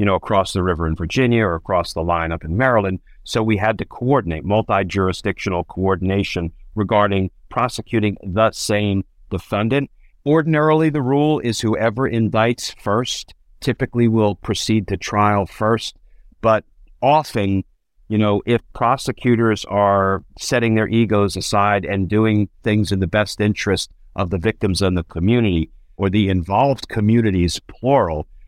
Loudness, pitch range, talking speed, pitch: -19 LUFS, 95-115 Hz, 145 wpm, 105 Hz